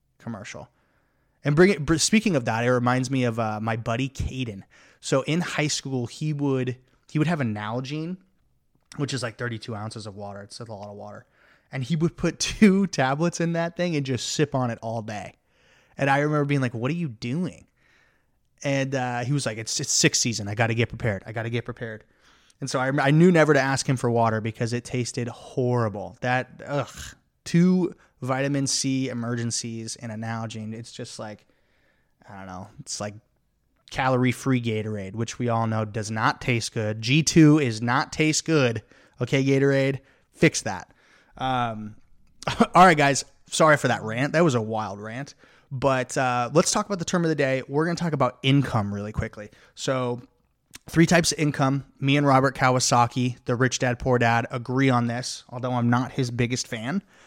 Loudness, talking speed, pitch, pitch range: -24 LUFS, 195 wpm, 125 Hz, 115-145 Hz